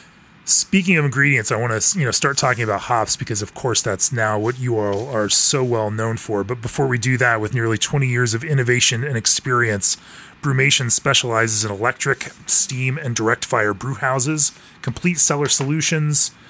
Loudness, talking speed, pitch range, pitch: -17 LUFS, 185 wpm, 110-140 Hz, 125 Hz